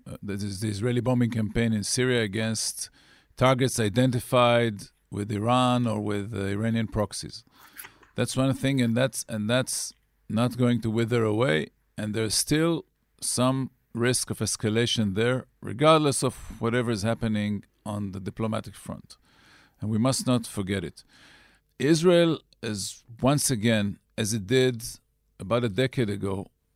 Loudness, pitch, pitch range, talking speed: -26 LUFS, 115 Hz, 105-125 Hz, 145 wpm